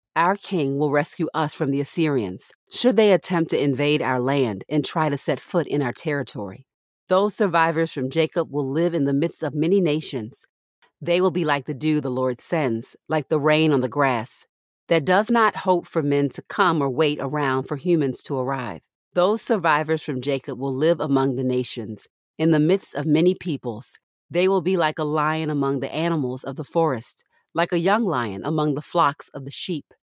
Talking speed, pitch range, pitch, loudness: 205 wpm, 135-170 Hz, 150 Hz, -22 LUFS